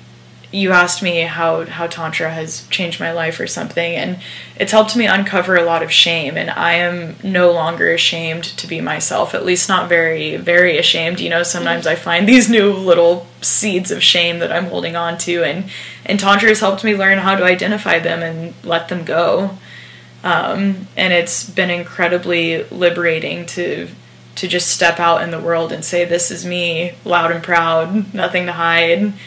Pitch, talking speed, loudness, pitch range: 175 Hz, 190 wpm, -14 LUFS, 165-185 Hz